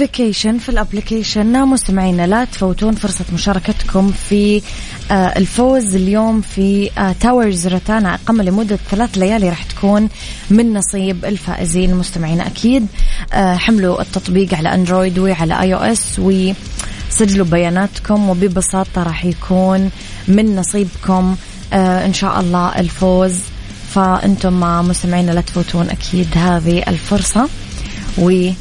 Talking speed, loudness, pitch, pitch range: 110 wpm, -14 LUFS, 190 Hz, 180-210 Hz